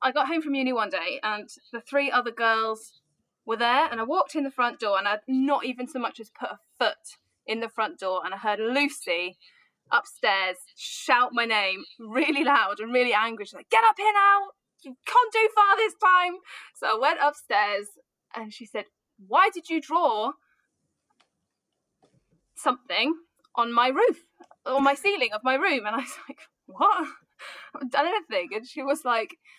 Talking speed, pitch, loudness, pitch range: 190 wpm, 260 Hz, -25 LUFS, 225-320 Hz